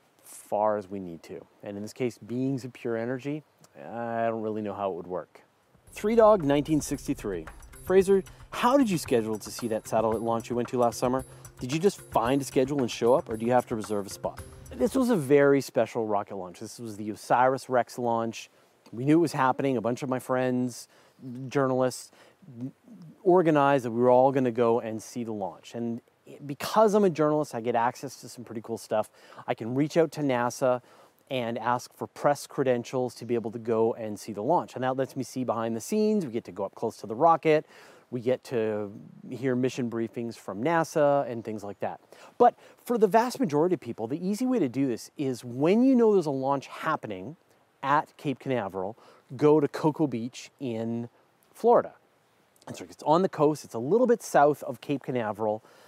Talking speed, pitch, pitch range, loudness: 210 wpm, 125 Hz, 115-145 Hz, -27 LUFS